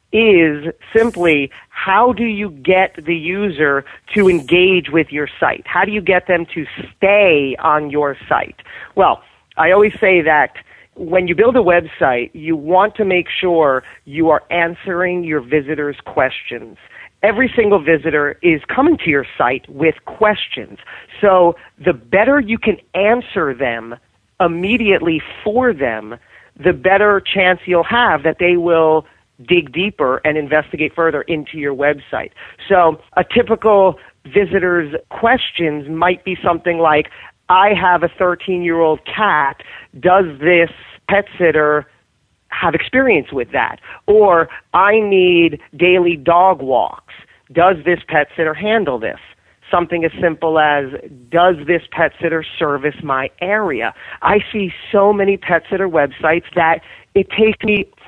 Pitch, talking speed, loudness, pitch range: 175 Hz, 145 wpm, -15 LUFS, 155-195 Hz